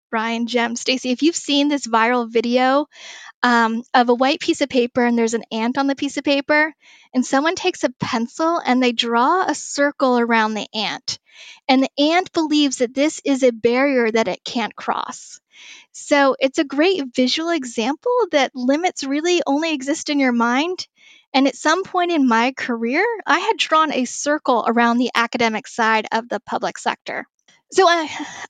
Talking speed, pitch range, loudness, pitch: 185 wpm, 240-305 Hz, -19 LUFS, 270 Hz